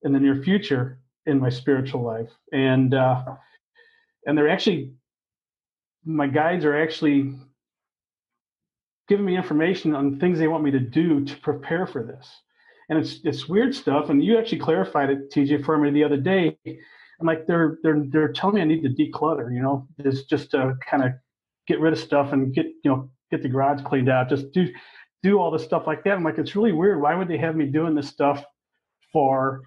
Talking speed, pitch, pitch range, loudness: 200 wpm, 150 Hz, 135-165 Hz, -22 LUFS